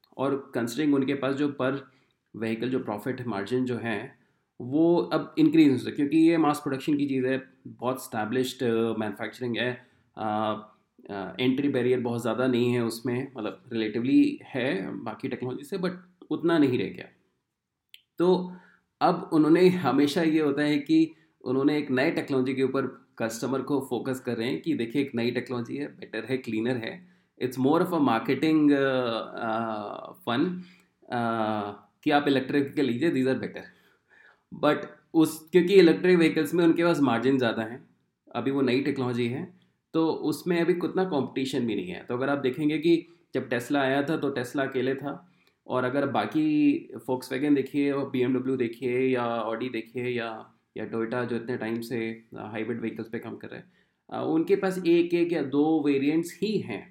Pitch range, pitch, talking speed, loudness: 120-155 Hz, 130 Hz, 175 wpm, -27 LUFS